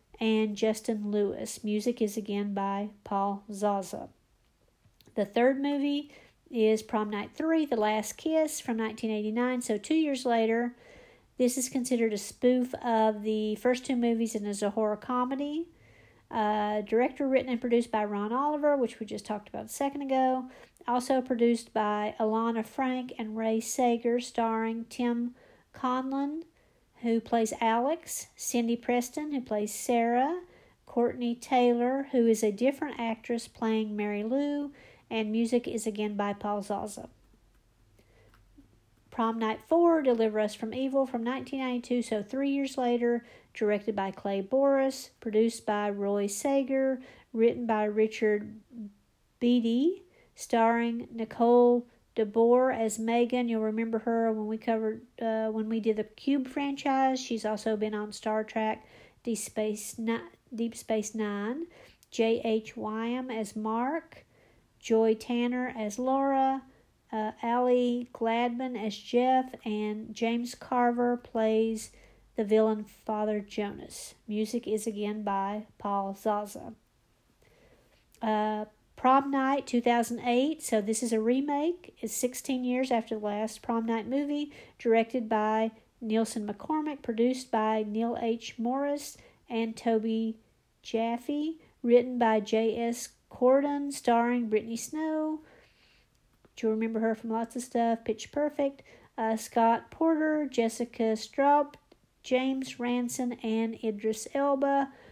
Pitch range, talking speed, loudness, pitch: 220-255 Hz, 130 wpm, -30 LUFS, 230 Hz